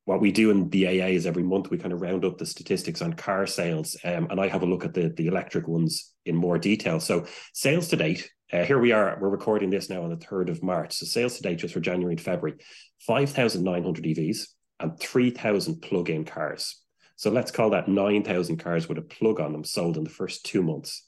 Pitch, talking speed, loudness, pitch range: 95 Hz, 235 wpm, -26 LUFS, 85-105 Hz